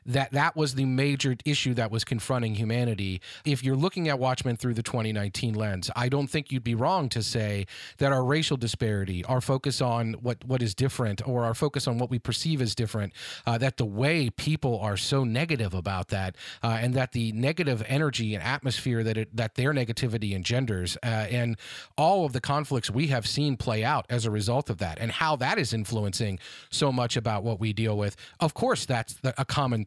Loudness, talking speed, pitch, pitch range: -28 LUFS, 210 wpm, 120 Hz, 110-135 Hz